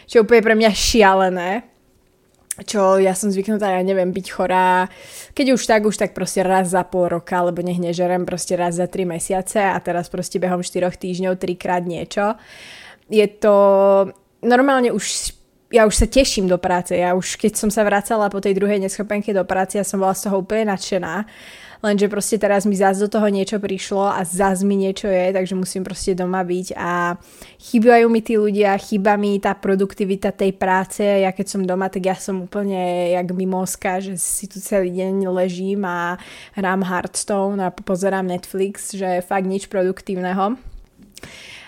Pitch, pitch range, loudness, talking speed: 195 Hz, 185-205 Hz, -19 LUFS, 180 wpm